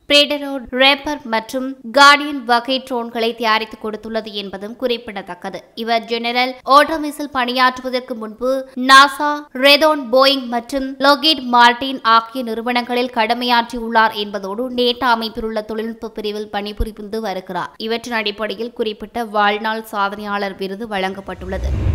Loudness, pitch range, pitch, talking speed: -16 LUFS, 220-260 Hz, 235 Hz, 105 wpm